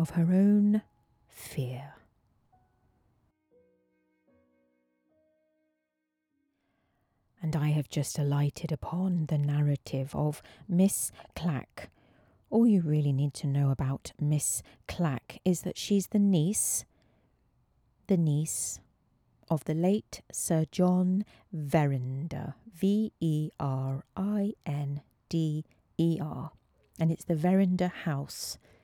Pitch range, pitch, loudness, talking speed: 135-185 Hz, 155 Hz, -30 LUFS, 105 wpm